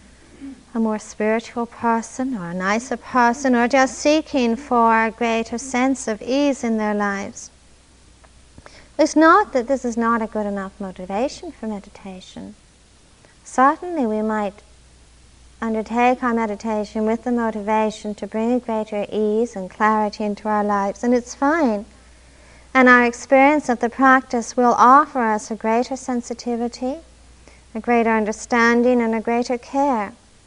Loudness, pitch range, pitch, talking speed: -19 LUFS, 215-255 Hz, 235 Hz, 145 wpm